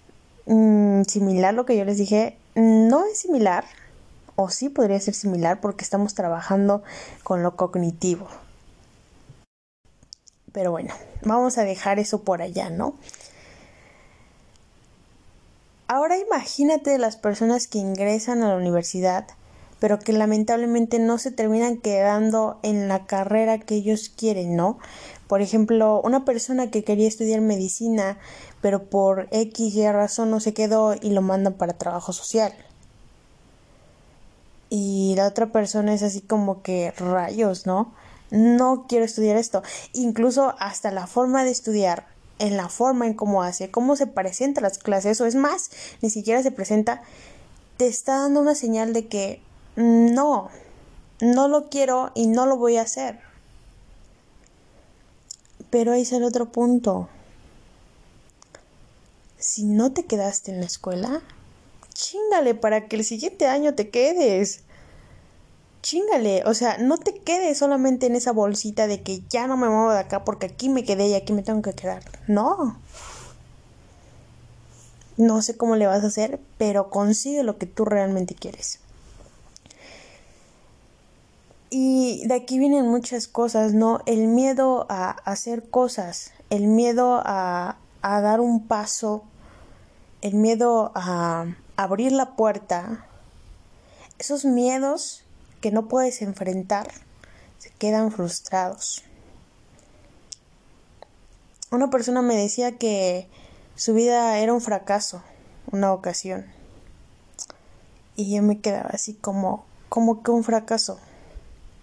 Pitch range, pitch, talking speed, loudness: 195-240 Hz, 215 Hz, 135 wpm, -22 LUFS